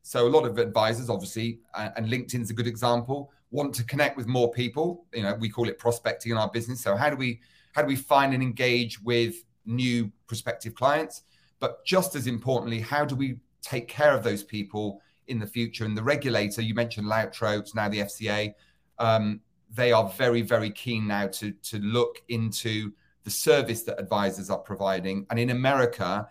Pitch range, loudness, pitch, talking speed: 105-125 Hz, -27 LUFS, 115 Hz, 190 wpm